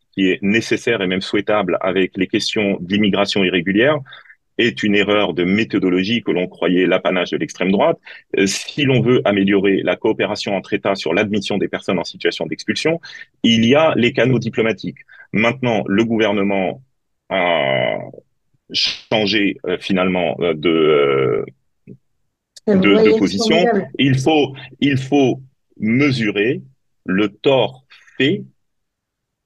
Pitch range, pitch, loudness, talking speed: 95-140 Hz, 110 Hz, -17 LUFS, 135 wpm